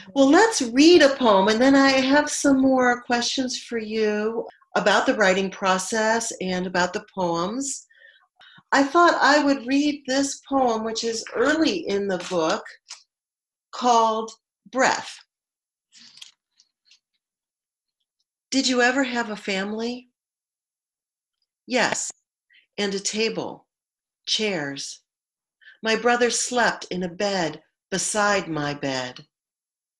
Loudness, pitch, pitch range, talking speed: -21 LUFS, 225 Hz, 195-265 Hz, 115 wpm